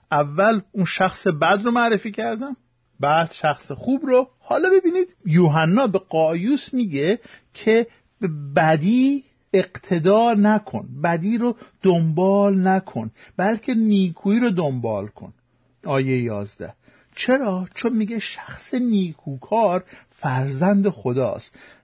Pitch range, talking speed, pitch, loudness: 160-230 Hz, 110 wpm, 190 Hz, -20 LUFS